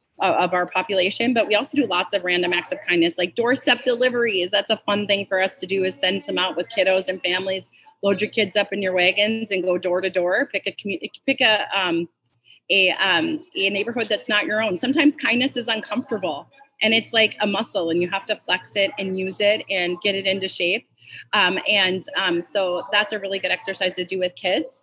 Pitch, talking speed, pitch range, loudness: 195 Hz, 225 wpm, 185-220 Hz, -21 LUFS